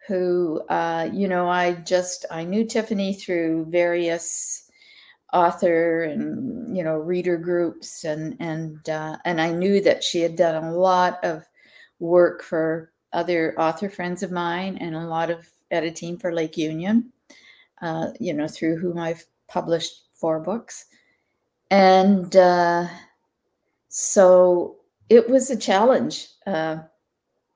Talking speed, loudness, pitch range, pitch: 135 wpm, -22 LUFS, 165-190 Hz, 175 Hz